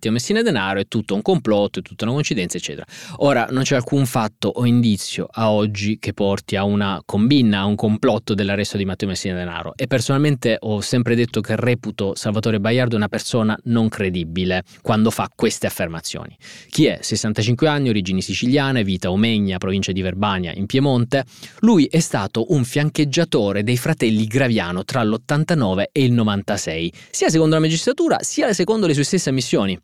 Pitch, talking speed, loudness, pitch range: 110 Hz, 175 wpm, -19 LUFS, 100-135 Hz